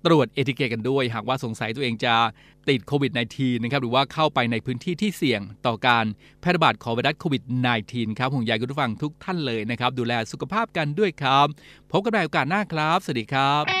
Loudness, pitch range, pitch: -23 LUFS, 120-155 Hz, 135 Hz